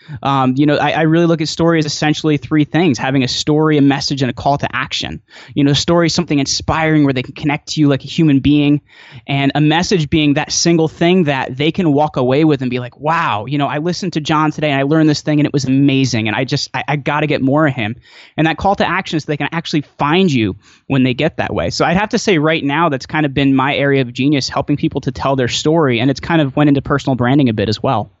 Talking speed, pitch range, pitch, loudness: 280 wpm, 135-155 Hz, 145 Hz, -14 LUFS